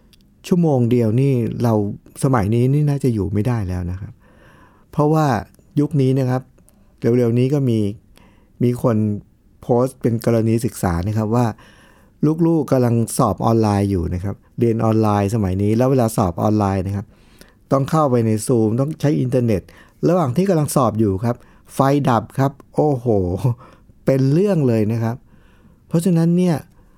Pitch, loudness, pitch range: 115 Hz, -18 LUFS, 105-135 Hz